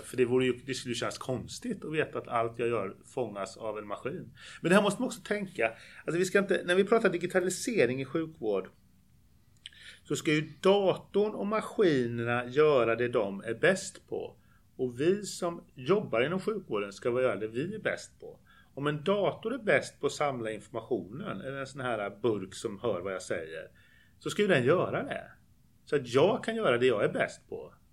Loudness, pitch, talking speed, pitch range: -30 LUFS, 155 Hz, 205 wpm, 125-200 Hz